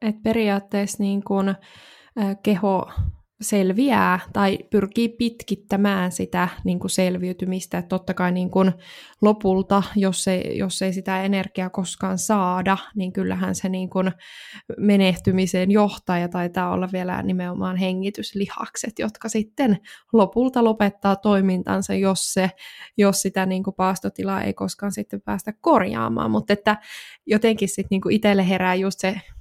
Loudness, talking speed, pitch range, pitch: -22 LUFS, 135 wpm, 185-205 Hz, 195 Hz